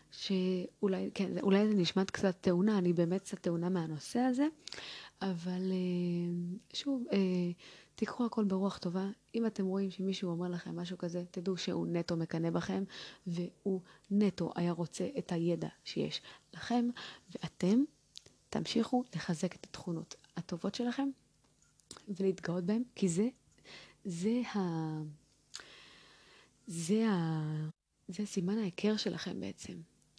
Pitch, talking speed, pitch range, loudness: 190 Hz, 120 wpm, 175-205 Hz, -36 LUFS